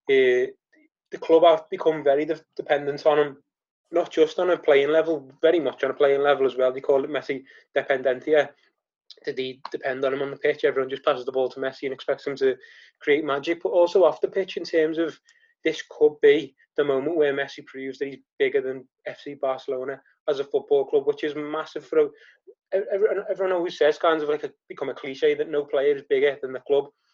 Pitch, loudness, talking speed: 165 Hz, -24 LUFS, 220 wpm